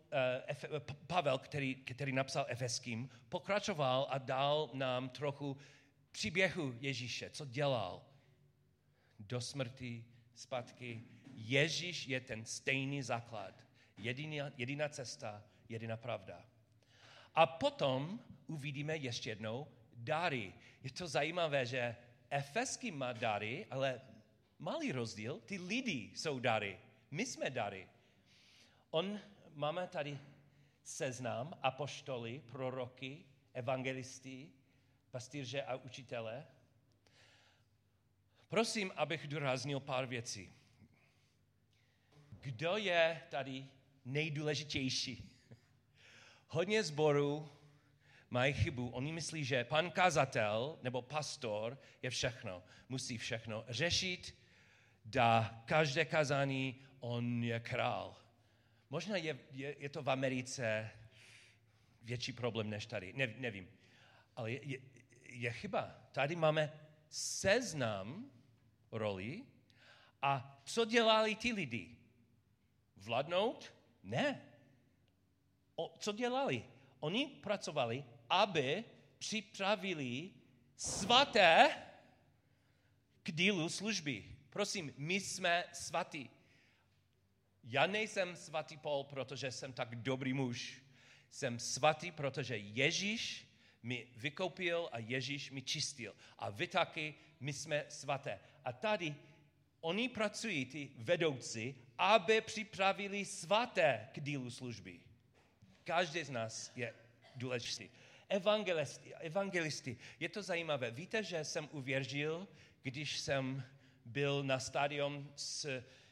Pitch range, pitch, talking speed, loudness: 120-150 Hz, 130 Hz, 100 wpm, -38 LUFS